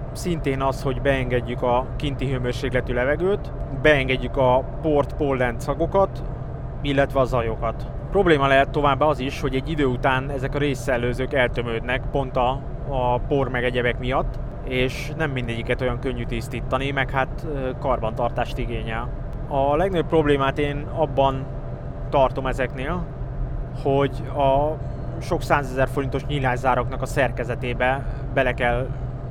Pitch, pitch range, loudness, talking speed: 135 Hz, 125-140 Hz, -23 LUFS, 125 wpm